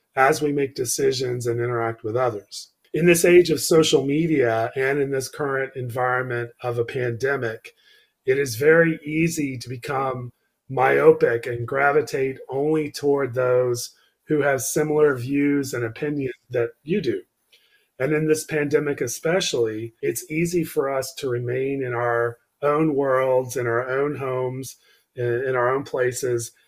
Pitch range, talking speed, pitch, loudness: 125-150 Hz, 150 wpm, 135 Hz, -22 LUFS